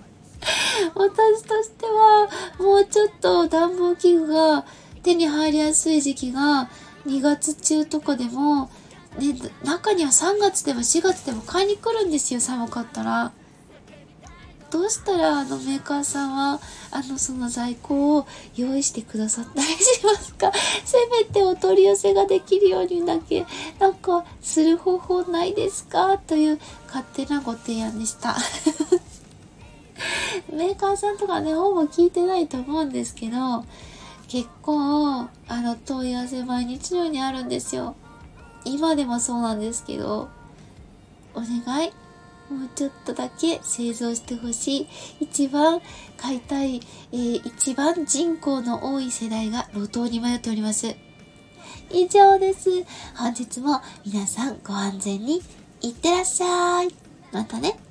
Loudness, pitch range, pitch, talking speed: -22 LUFS, 245-360 Hz, 295 Hz, 270 characters per minute